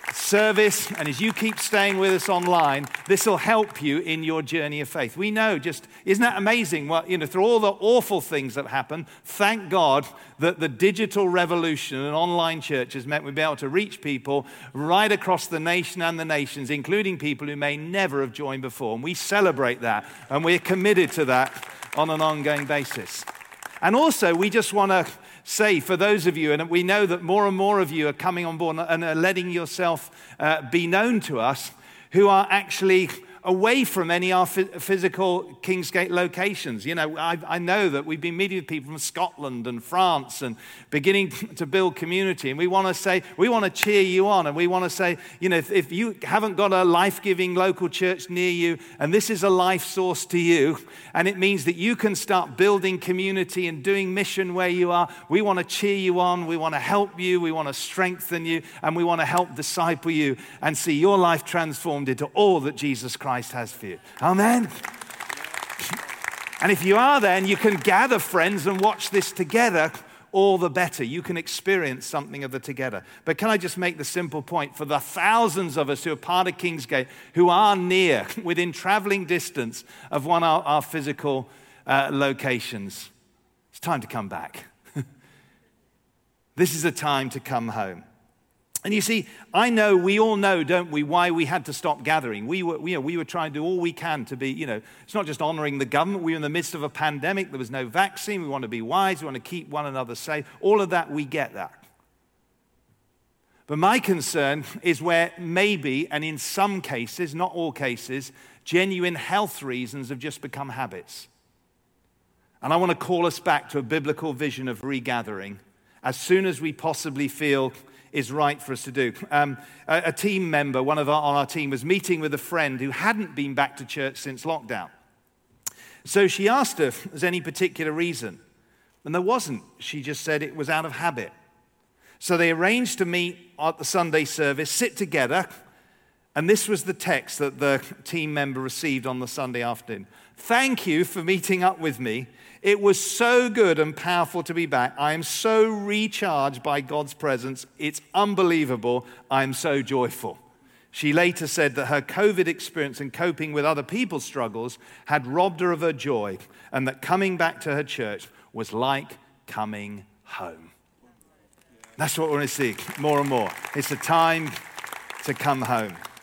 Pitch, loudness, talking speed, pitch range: 165 Hz, -23 LUFS, 200 wpm, 145-185 Hz